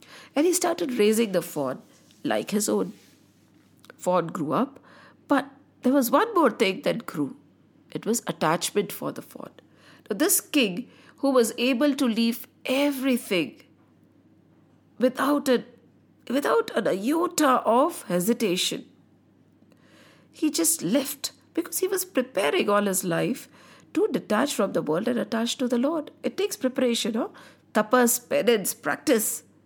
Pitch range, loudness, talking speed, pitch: 225-290 Hz, -25 LUFS, 140 wpm, 255 Hz